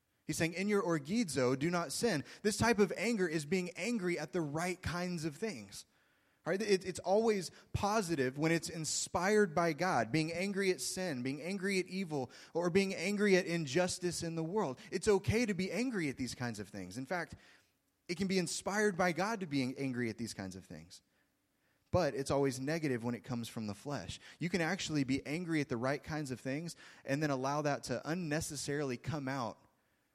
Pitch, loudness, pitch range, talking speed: 165 Hz, -36 LUFS, 135-185 Hz, 205 wpm